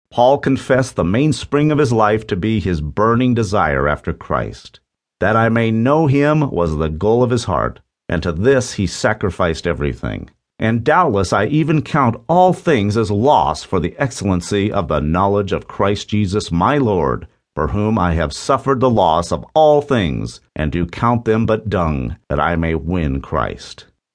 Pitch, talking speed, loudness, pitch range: 105 Hz, 180 wpm, -17 LUFS, 85-125 Hz